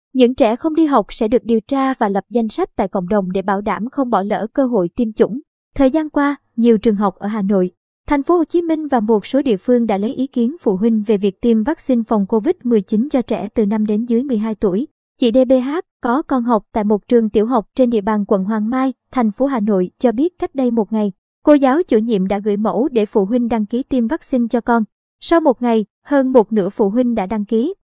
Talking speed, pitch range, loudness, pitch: 255 wpm, 215-265 Hz, -17 LUFS, 235 Hz